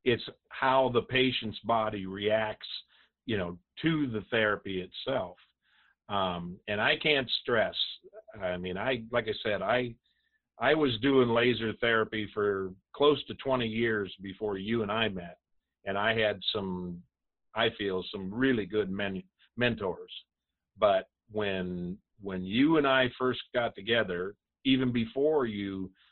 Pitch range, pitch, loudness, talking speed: 95-125 Hz, 110 Hz, -30 LUFS, 140 wpm